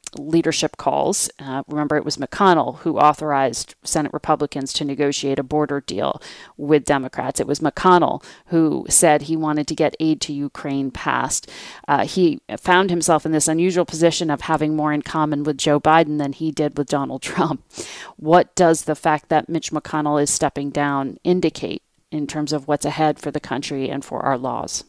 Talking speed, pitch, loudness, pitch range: 185 wpm, 150 Hz, -20 LUFS, 145-160 Hz